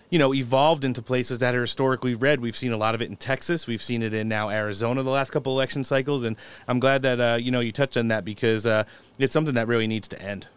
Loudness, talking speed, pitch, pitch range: -24 LUFS, 270 wpm, 125 Hz, 115-135 Hz